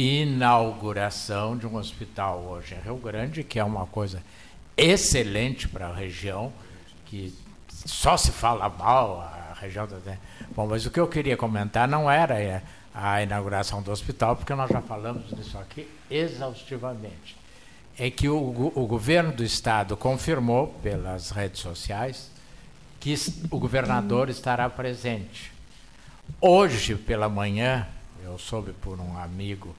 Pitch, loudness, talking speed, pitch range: 110 Hz, -26 LUFS, 135 wpm, 100-130 Hz